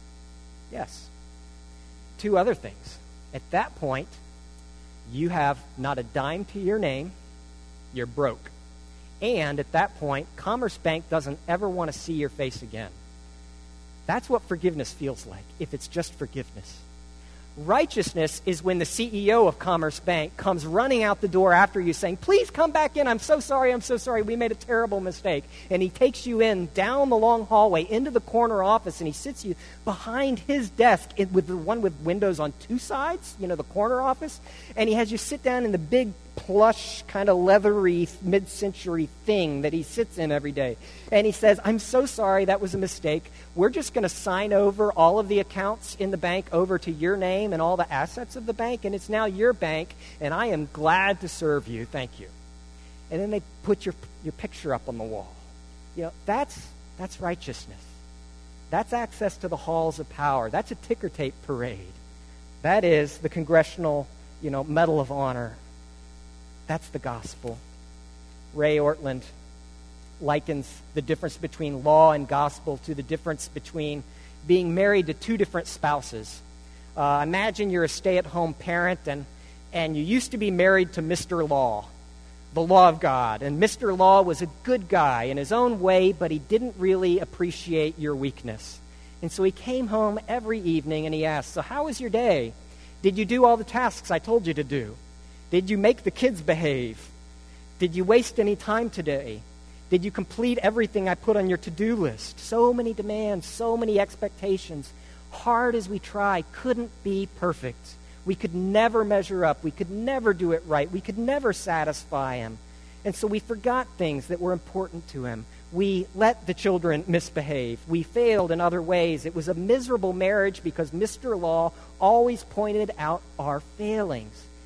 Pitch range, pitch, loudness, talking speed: 140-210 Hz, 175 Hz, -25 LUFS, 185 wpm